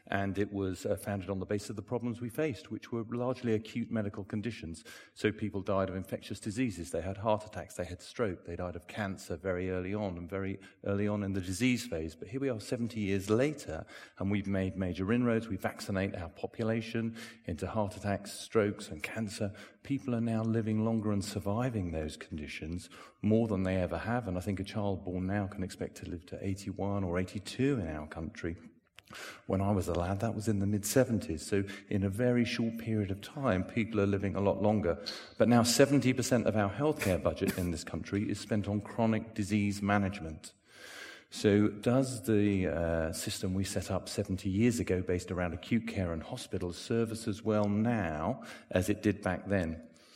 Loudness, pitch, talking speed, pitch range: -33 LUFS, 100 Hz, 200 wpm, 95-110 Hz